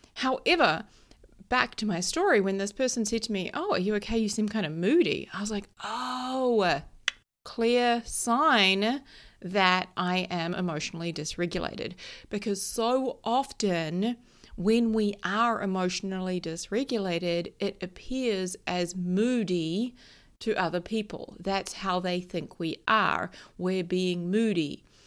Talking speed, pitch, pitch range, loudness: 130 wpm, 200 Hz, 180-230 Hz, -28 LUFS